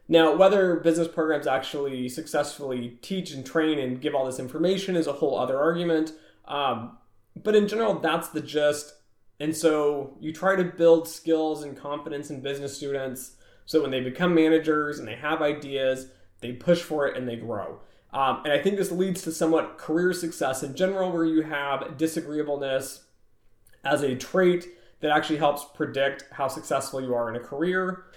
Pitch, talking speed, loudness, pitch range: 150 Hz, 180 wpm, -26 LUFS, 135-165 Hz